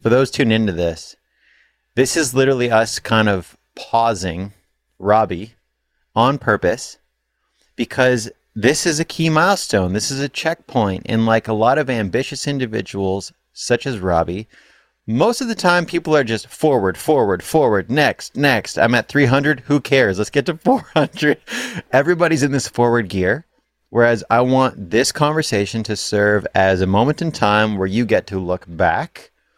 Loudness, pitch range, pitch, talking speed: -17 LUFS, 100-145 Hz, 120 Hz, 160 wpm